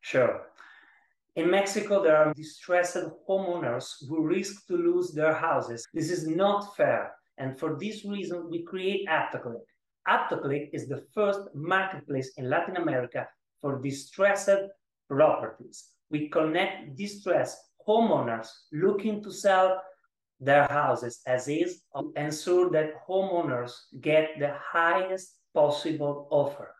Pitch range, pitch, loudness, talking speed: 145-195 Hz, 170 Hz, -28 LUFS, 125 wpm